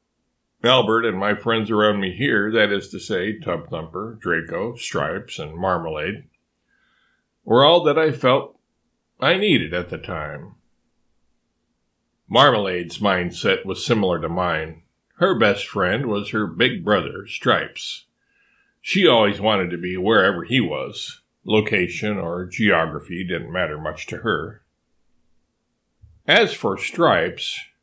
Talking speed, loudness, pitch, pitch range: 125 wpm, -20 LUFS, 95 Hz, 85-105 Hz